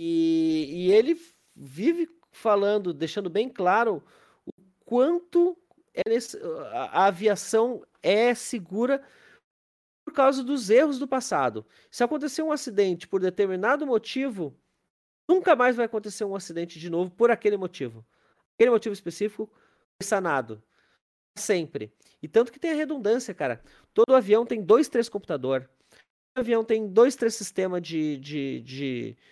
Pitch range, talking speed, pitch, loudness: 185-280 Hz, 140 wpm, 225 Hz, -25 LUFS